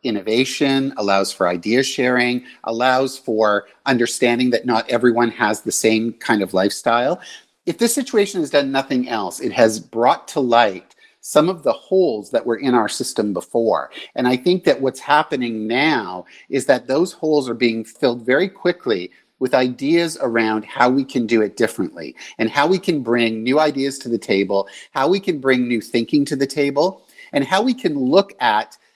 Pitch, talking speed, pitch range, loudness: 130 Hz, 185 wpm, 115-155 Hz, -18 LUFS